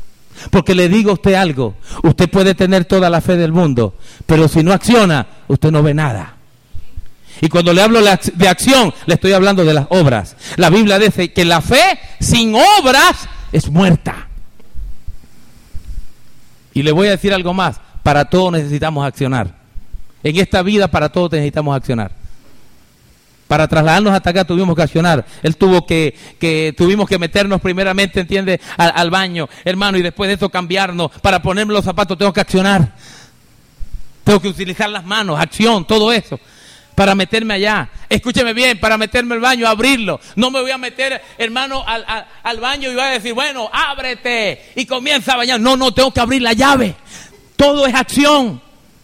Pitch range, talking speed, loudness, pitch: 160-220 Hz, 175 wpm, -13 LUFS, 190 Hz